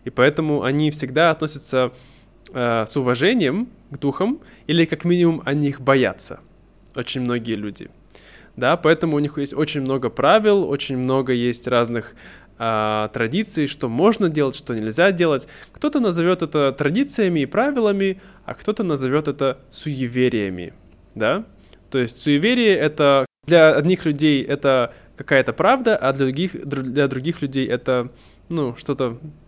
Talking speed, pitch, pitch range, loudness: 140 wpm, 140 Hz, 125-165 Hz, -20 LUFS